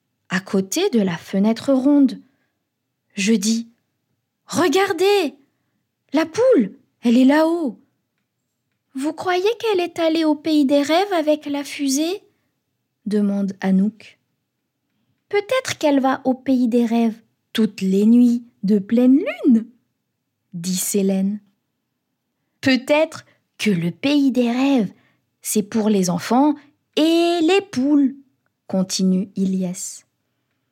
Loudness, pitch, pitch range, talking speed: -19 LUFS, 260 Hz, 205-305 Hz, 115 wpm